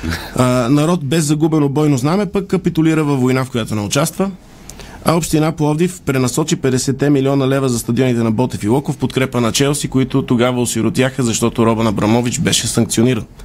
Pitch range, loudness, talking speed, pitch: 120-155 Hz, -15 LUFS, 170 wpm, 130 Hz